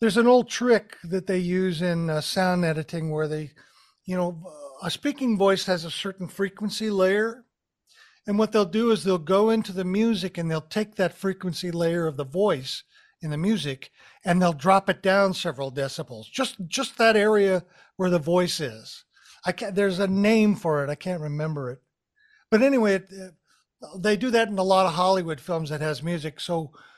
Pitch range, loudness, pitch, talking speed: 165-210 Hz, -24 LUFS, 185 Hz, 195 wpm